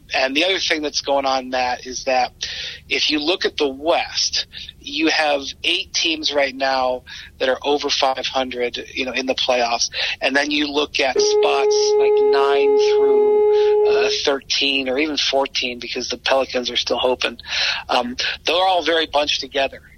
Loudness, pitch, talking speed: -18 LUFS, 145 Hz, 175 wpm